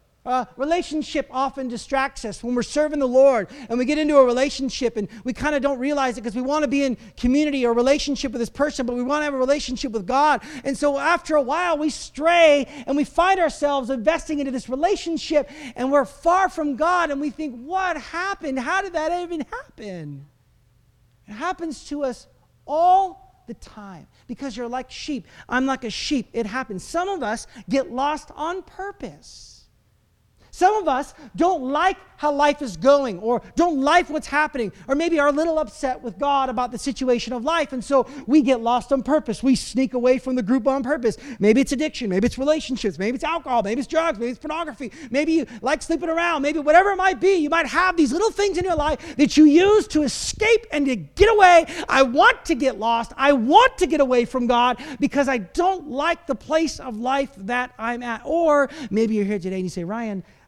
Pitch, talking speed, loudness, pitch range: 280 Hz, 215 wpm, -21 LUFS, 250-315 Hz